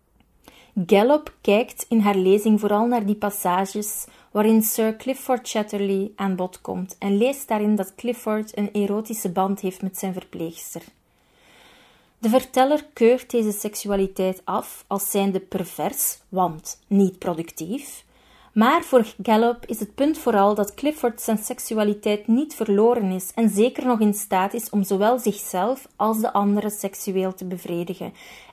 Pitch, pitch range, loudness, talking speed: 210 Hz, 195-235 Hz, -22 LUFS, 145 wpm